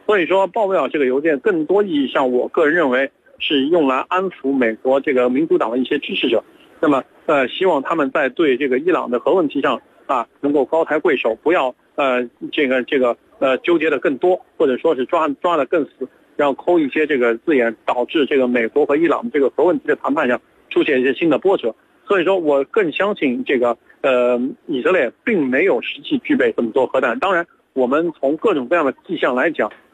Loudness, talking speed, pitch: -18 LUFS, 320 characters per minute, 170 Hz